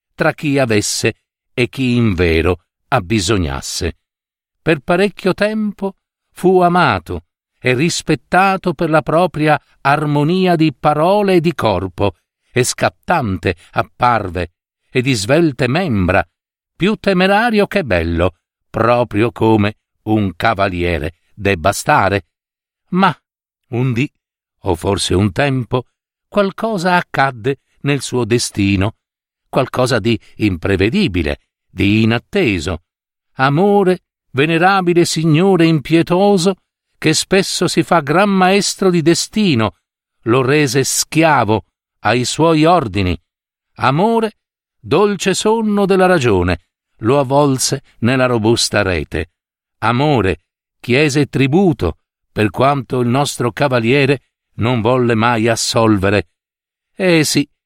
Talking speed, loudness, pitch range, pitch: 105 wpm, -15 LUFS, 105-170 Hz, 130 Hz